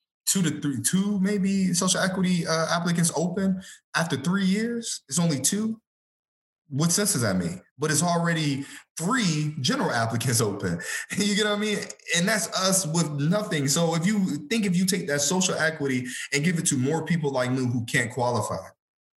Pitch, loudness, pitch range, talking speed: 170 Hz, -25 LUFS, 145-195 Hz, 185 wpm